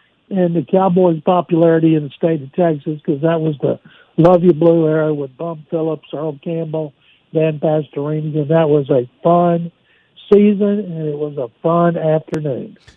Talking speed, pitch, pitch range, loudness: 165 wpm, 165 Hz, 155-170 Hz, -16 LUFS